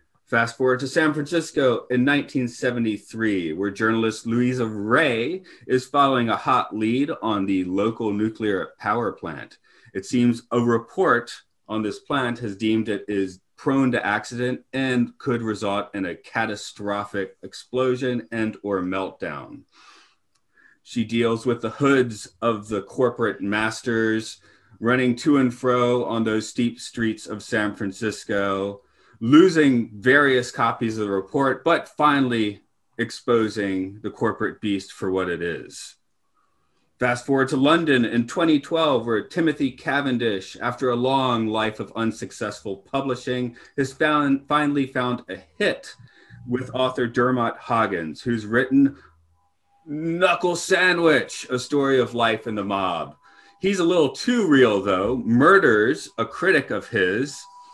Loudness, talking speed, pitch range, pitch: -22 LUFS, 135 wpm, 110-135 Hz, 120 Hz